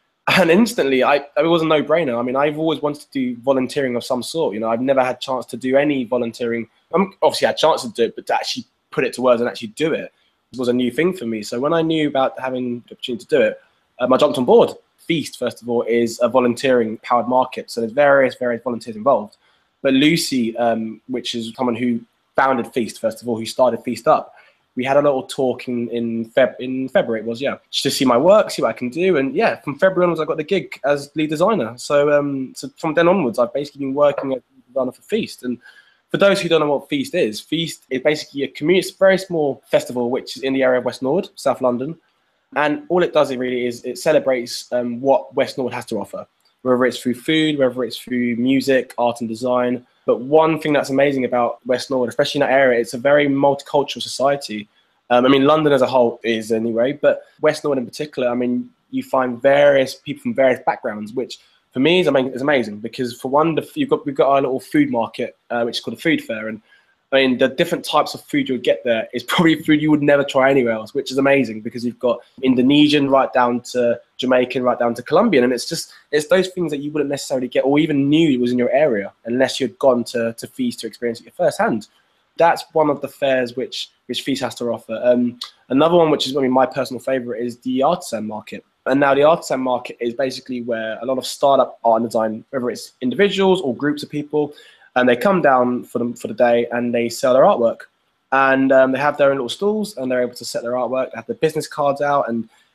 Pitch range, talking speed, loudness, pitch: 120-150 Hz, 245 wpm, -18 LUFS, 130 Hz